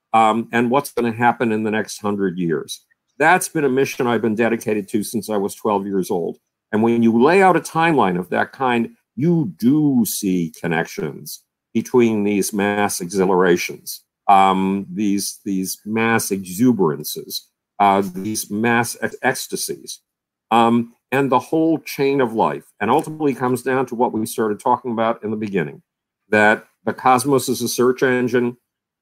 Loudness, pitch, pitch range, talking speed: -19 LUFS, 115 Hz, 105-125 Hz, 165 wpm